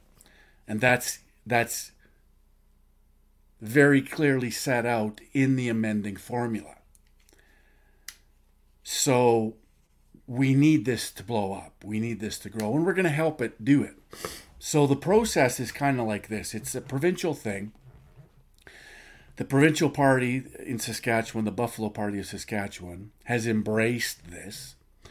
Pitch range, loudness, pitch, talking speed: 100-135 Hz, -26 LUFS, 115 Hz, 135 wpm